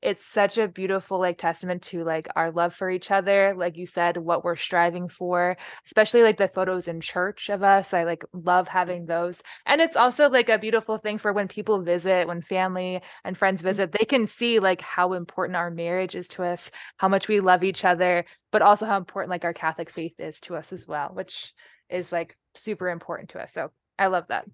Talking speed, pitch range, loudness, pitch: 220 wpm, 175-200 Hz, -24 LUFS, 185 Hz